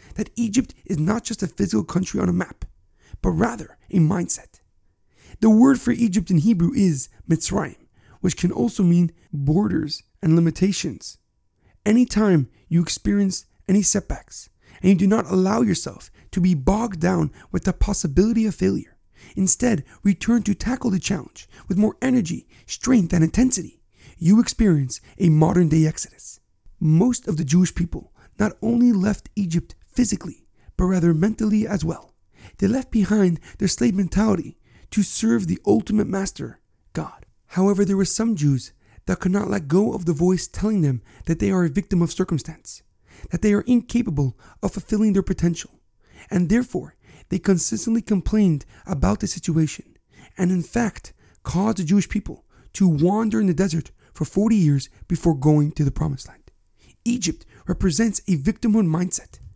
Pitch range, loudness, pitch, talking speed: 160-210 Hz, -21 LUFS, 185 Hz, 160 wpm